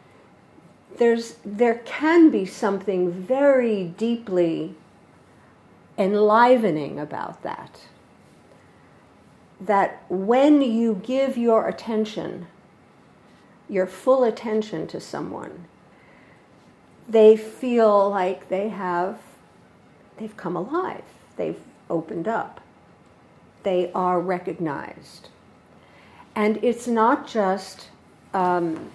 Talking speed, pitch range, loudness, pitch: 85 wpm, 185-235 Hz, -22 LUFS, 210 Hz